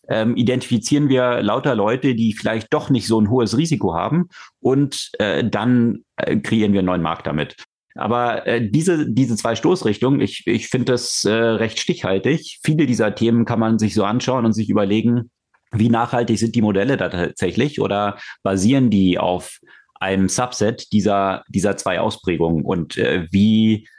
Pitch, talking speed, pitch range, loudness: 115 Hz, 170 wpm, 105-125 Hz, -19 LUFS